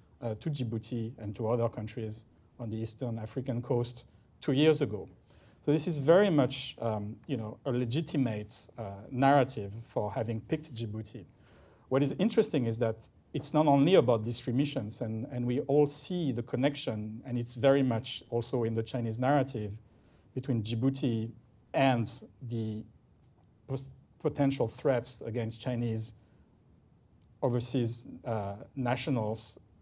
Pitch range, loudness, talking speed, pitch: 110-135 Hz, -31 LUFS, 145 wpm, 120 Hz